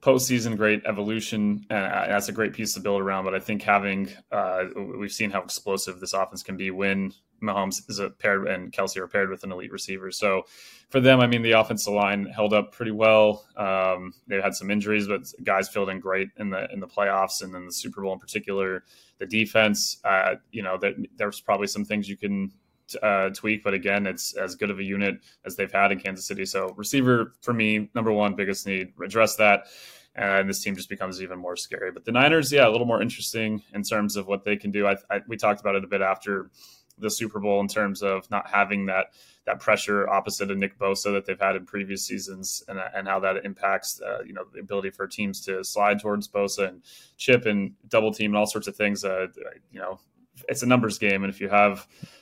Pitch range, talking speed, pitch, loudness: 95-105 Hz, 230 wpm, 100 Hz, -25 LUFS